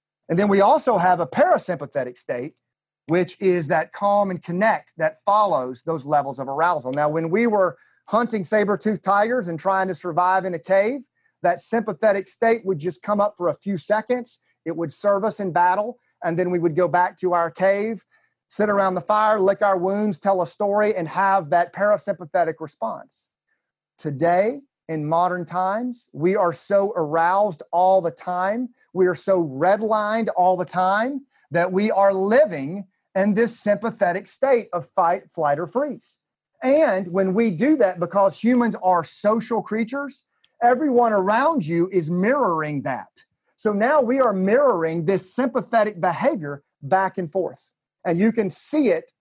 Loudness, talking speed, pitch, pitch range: -21 LUFS, 170 wpm, 195 Hz, 175-220 Hz